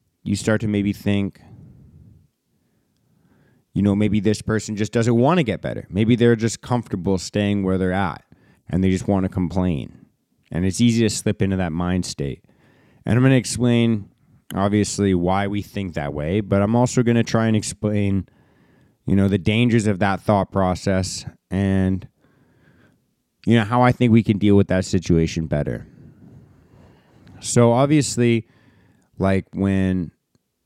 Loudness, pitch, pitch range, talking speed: -20 LUFS, 100 Hz, 95-115 Hz, 160 wpm